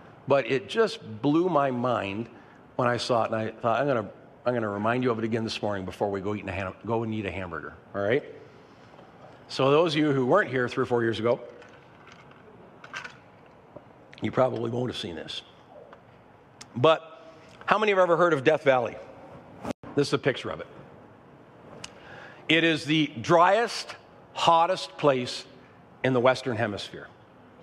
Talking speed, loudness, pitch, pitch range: 175 wpm, -26 LUFS, 125 Hz, 110-145 Hz